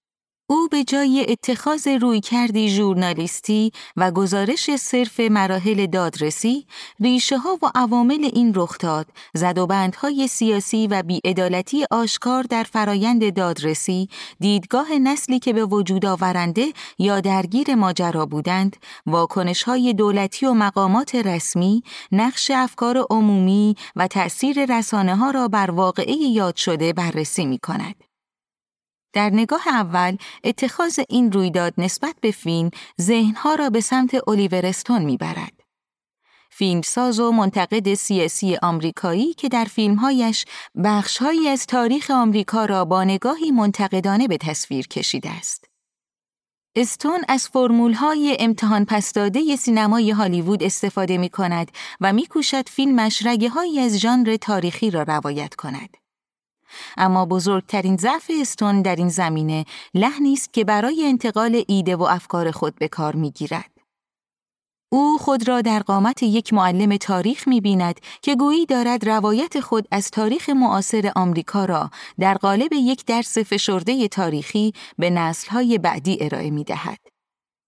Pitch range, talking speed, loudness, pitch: 185-245 Hz, 125 wpm, -20 LUFS, 210 Hz